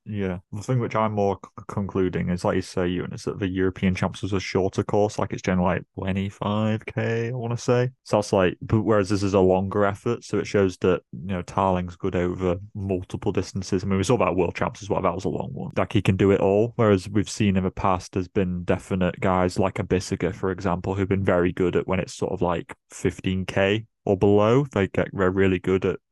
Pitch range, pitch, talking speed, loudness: 95-105 Hz, 95 Hz, 245 wpm, -24 LUFS